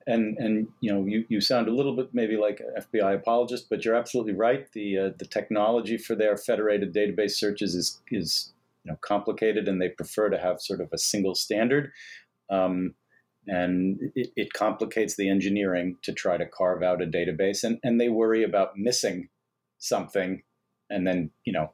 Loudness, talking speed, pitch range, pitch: -27 LUFS, 190 wpm, 95-110 Hz, 105 Hz